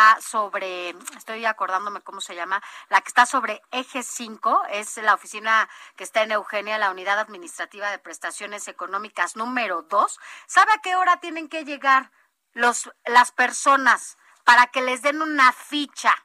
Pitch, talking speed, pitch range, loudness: 225 Hz, 160 wpm, 200-265 Hz, -21 LUFS